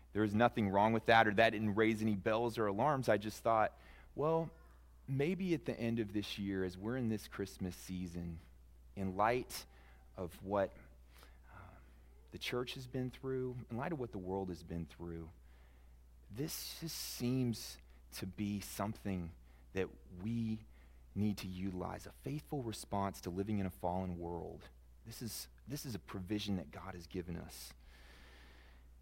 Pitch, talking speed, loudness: 95 Hz, 170 wpm, -39 LUFS